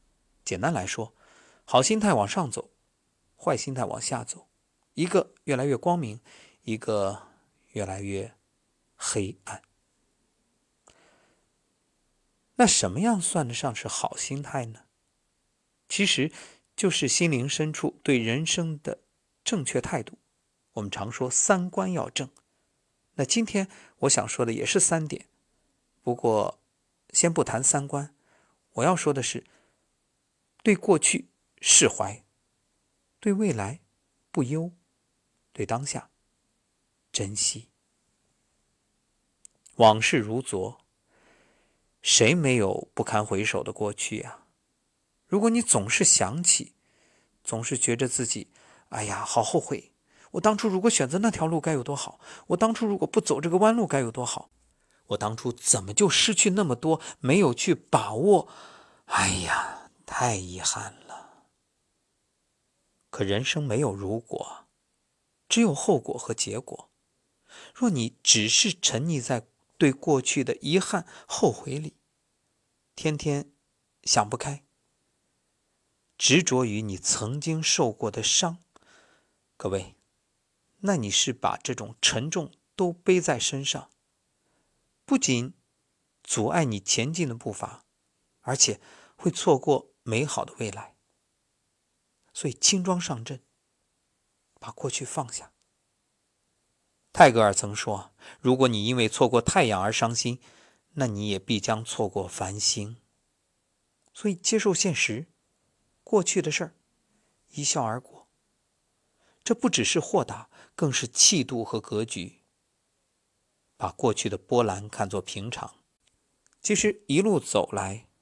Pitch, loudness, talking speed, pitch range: 135 Hz, -25 LUFS, 180 characters per minute, 110-175 Hz